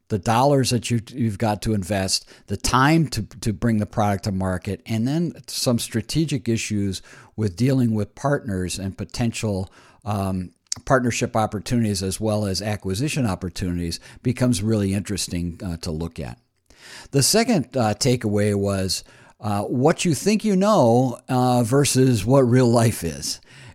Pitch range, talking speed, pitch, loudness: 100-125 Hz, 150 wpm, 110 Hz, -22 LUFS